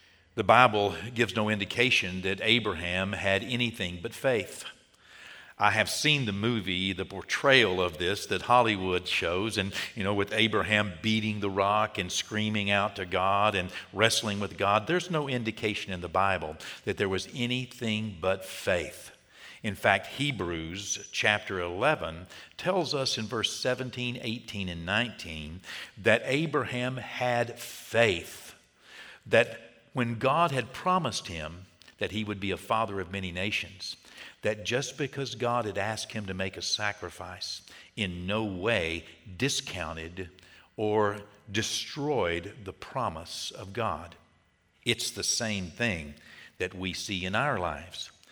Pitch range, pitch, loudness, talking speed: 95-115 Hz, 105 Hz, -29 LUFS, 145 wpm